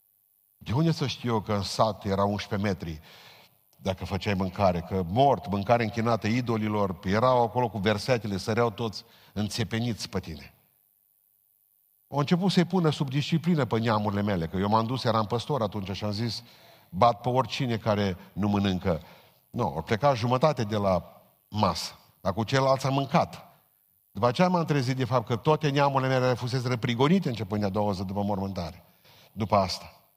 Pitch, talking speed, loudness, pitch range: 115 Hz, 175 wpm, -27 LUFS, 100-130 Hz